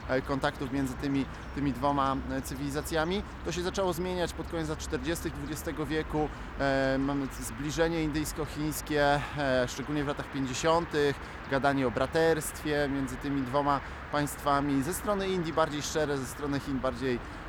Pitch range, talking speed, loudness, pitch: 135-155 Hz, 140 wpm, -31 LUFS, 145 Hz